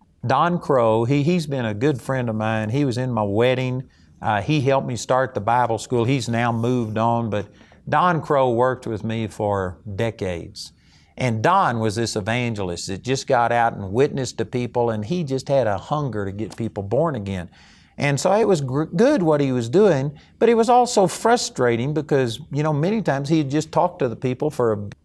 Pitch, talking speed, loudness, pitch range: 125 Hz, 210 wpm, -21 LUFS, 110-150 Hz